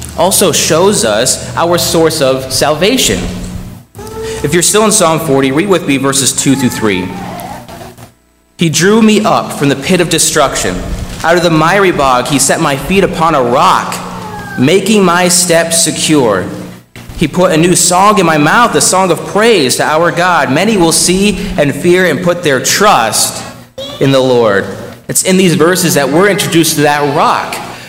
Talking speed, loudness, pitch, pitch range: 175 wpm, -9 LUFS, 160 Hz, 135-180 Hz